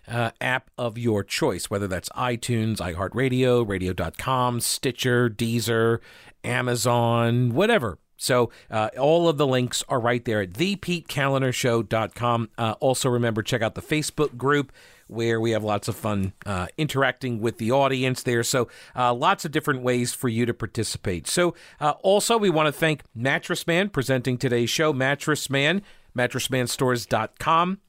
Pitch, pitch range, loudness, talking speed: 125 Hz, 115-140 Hz, -24 LUFS, 145 wpm